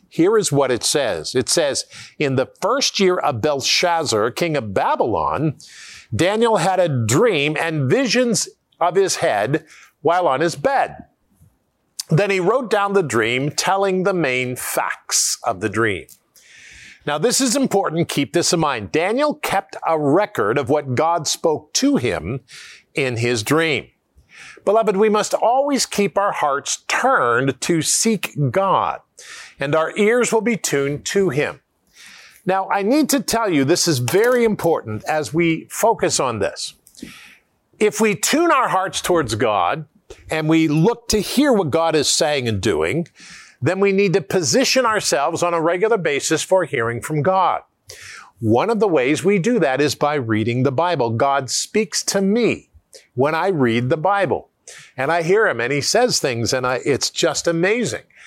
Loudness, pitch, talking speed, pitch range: -18 LUFS, 180 Hz, 170 wpm, 150-220 Hz